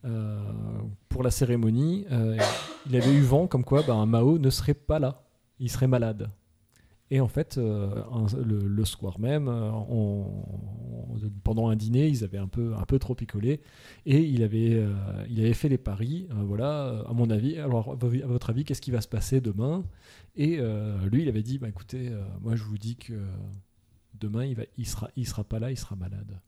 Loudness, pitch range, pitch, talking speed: -28 LUFS, 105-130 Hz, 115 Hz, 215 wpm